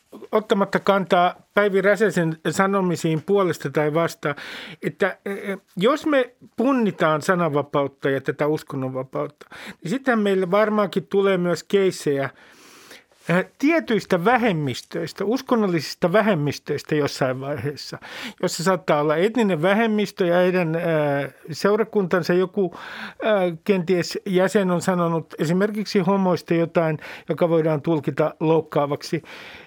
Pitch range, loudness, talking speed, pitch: 155-205 Hz, -22 LUFS, 100 wpm, 180 Hz